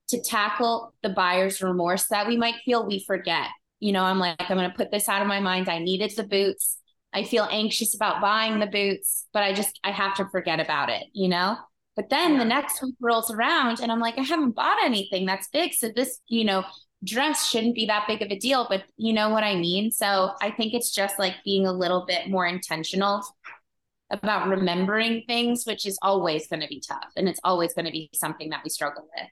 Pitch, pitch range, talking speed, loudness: 200 Hz, 185-230 Hz, 230 wpm, -25 LUFS